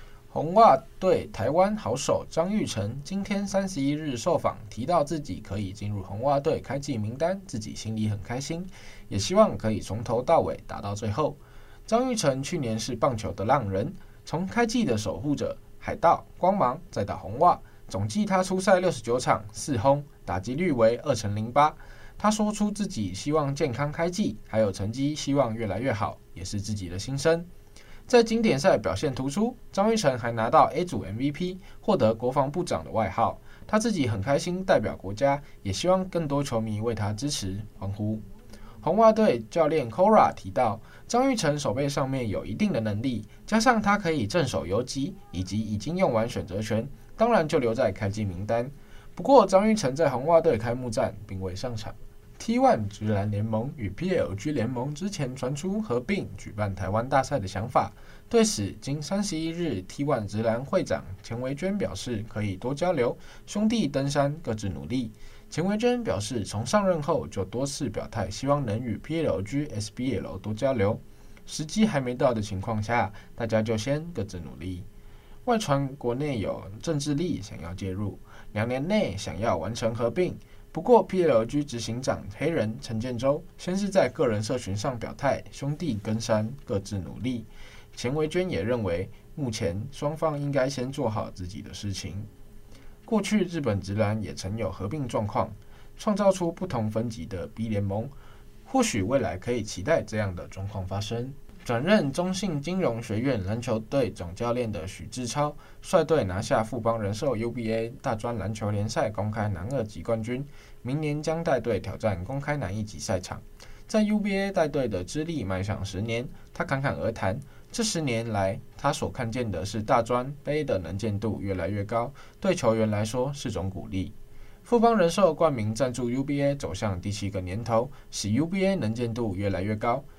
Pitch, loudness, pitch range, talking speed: 120 Hz, -27 LUFS, 105-150 Hz, 270 characters per minute